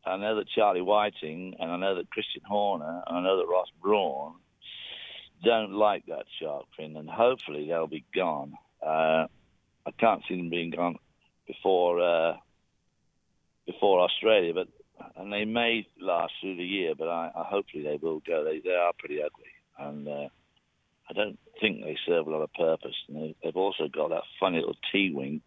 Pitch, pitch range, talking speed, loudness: 90 Hz, 80-110 Hz, 185 wpm, -29 LUFS